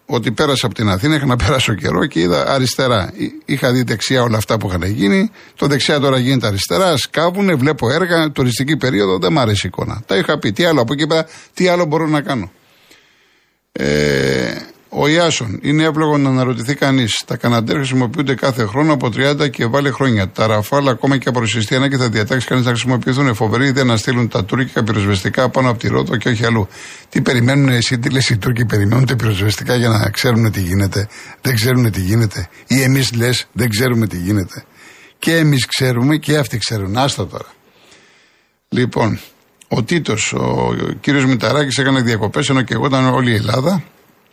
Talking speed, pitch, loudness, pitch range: 190 wpm, 125 Hz, -15 LUFS, 110-140 Hz